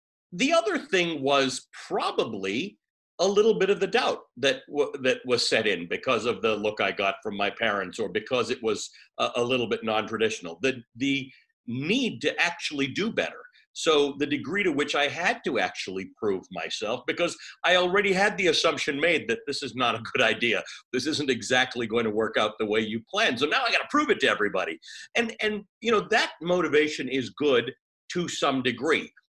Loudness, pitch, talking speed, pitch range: -26 LUFS, 150 Hz, 200 wpm, 125-210 Hz